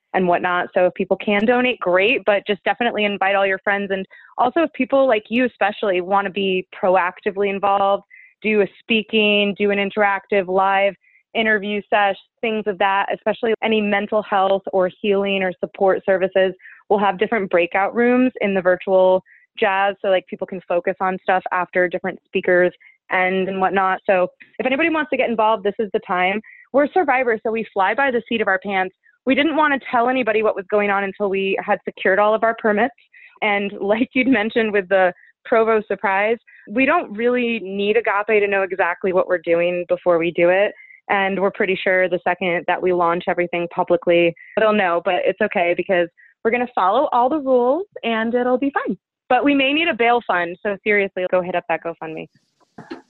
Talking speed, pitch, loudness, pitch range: 200 wpm, 200 Hz, -19 LUFS, 185-225 Hz